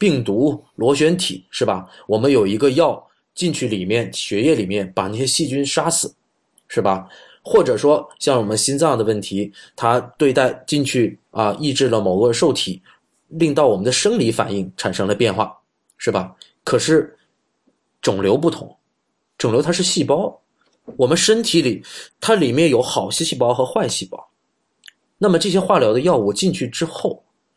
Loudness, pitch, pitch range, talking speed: -18 LUFS, 145 Hz, 110-165 Hz, 245 characters per minute